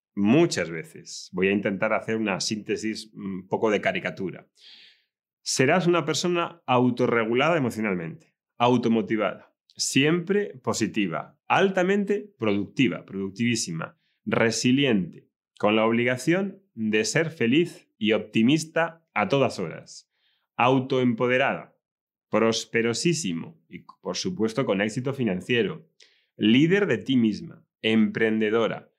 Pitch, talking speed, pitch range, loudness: 120 Hz, 100 wpm, 110-160 Hz, -24 LUFS